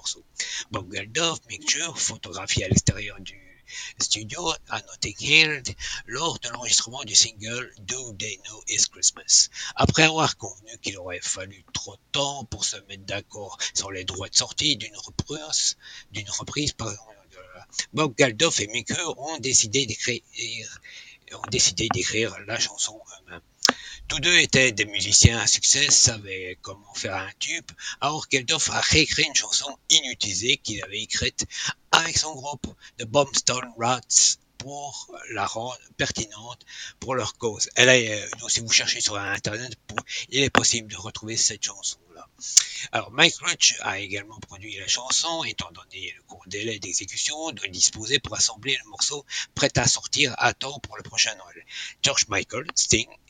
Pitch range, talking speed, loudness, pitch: 105-135 Hz, 155 wpm, -22 LUFS, 115 Hz